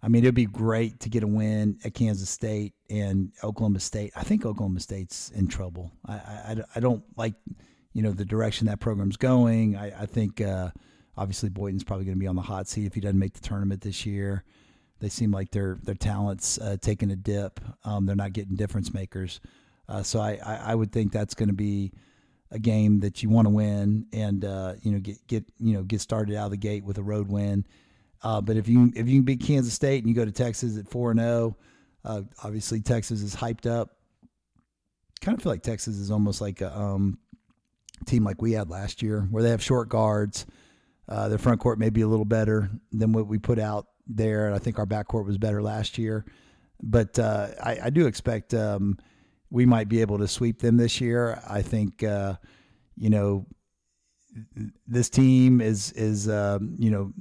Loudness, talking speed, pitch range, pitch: -26 LUFS, 215 wpm, 100-115 Hz, 105 Hz